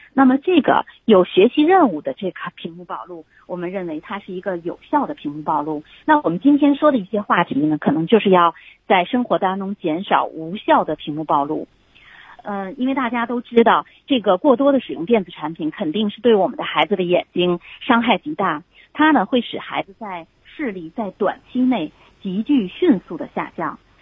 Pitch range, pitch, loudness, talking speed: 175-270 Hz, 210 Hz, -19 LUFS, 295 characters per minute